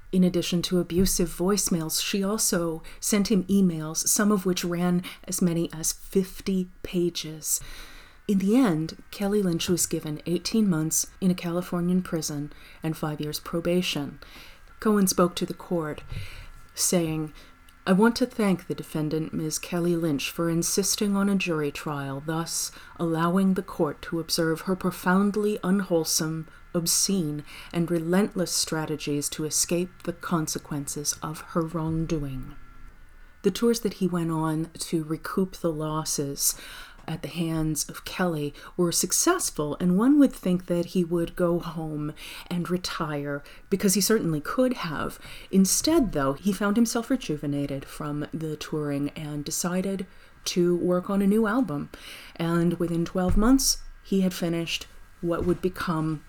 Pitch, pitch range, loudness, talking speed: 170 Hz, 155-190 Hz, -26 LUFS, 145 wpm